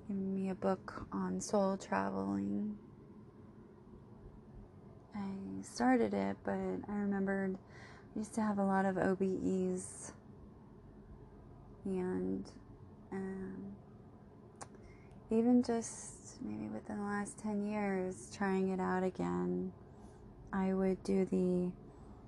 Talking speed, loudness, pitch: 100 wpm, -37 LUFS, 190 Hz